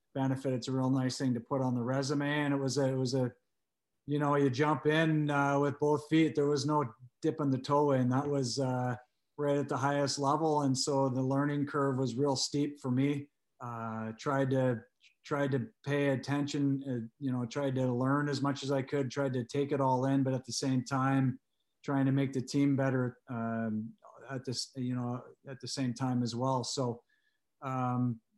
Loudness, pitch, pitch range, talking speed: -32 LUFS, 135 Hz, 125-145 Hz, 215 wpm